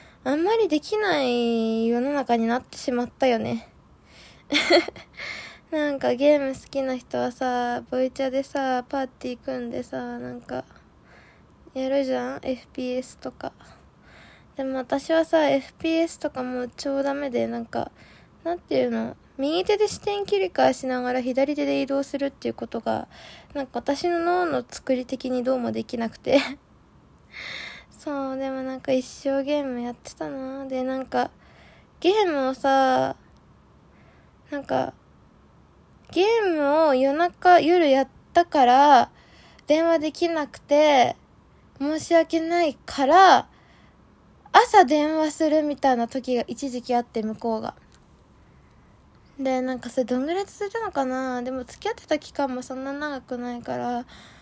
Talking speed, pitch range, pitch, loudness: 270 characters per minute, 250-310 Hz, 270 Hz, -24 LUFS